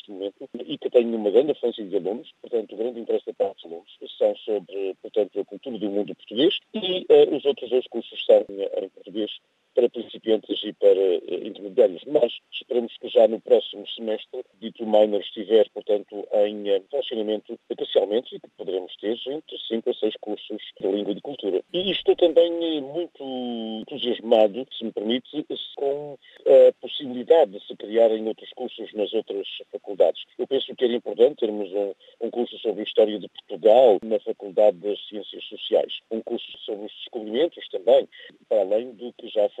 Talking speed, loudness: 175 wpm, -24 LUFS